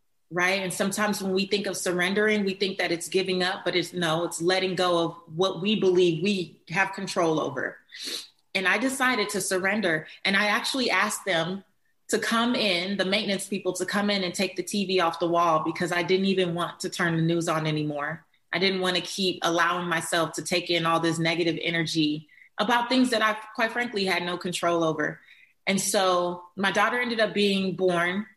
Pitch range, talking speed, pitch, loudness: 170-200 Hz, 205 wpm, 185 Hz, -25 LUFS